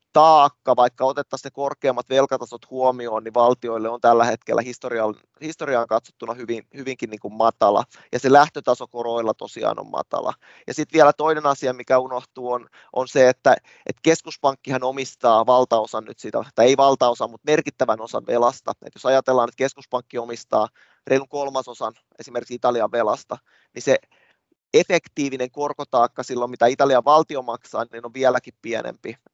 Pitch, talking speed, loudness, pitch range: 130 Hz, 150 wpm, -21 LUFS, 120-140 Hz